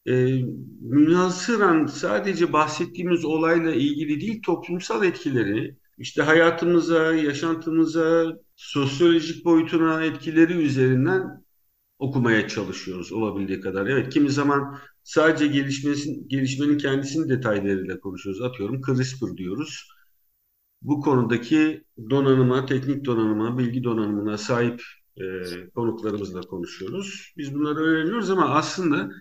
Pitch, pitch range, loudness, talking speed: 145 Hz, 120-165 Hz, -23 LUFS, 100 wpm